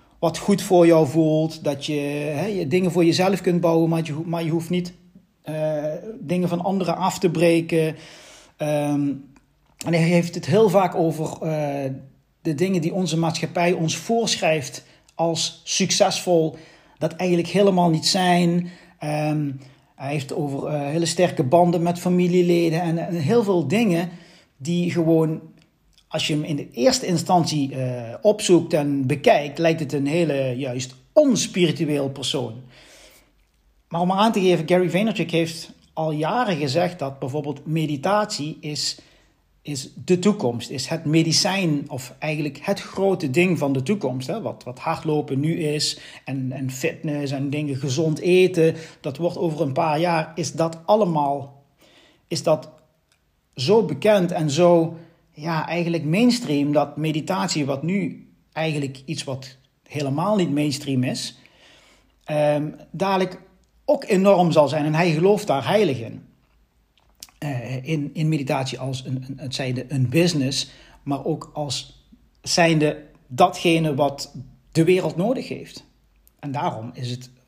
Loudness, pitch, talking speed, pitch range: -22 LUFS, 160 Hz, 150 wpm, 145-175 Hz